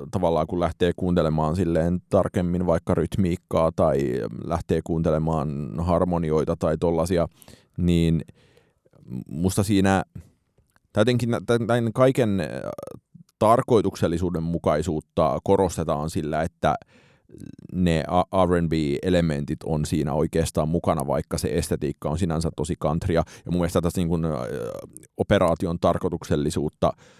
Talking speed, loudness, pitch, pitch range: 95 wpm, -24 LUFS, 85 Hz, 80-95 Hz